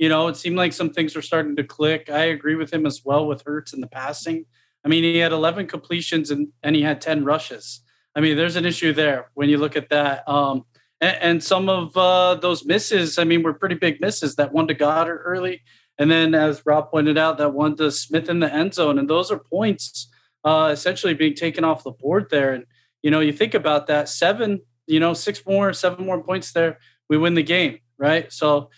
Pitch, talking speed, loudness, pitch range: 155 Hz, 235 wpm, -20 LUFS, 150-170 Hz